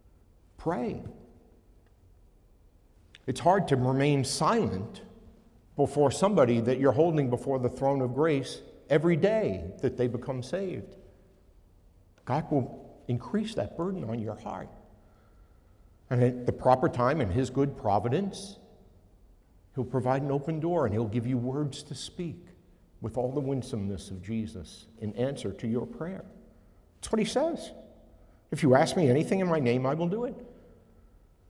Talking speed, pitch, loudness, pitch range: 150 wpm, 125 Hz, -29 LUFS, 100-145 Hz